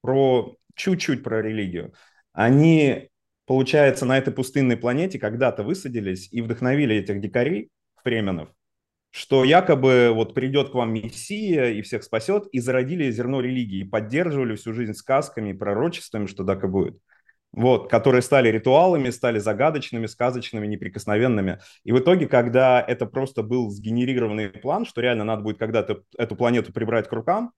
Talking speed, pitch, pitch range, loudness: 145 wpm, 125 Hz, 110-135 Hz, -22 LUFS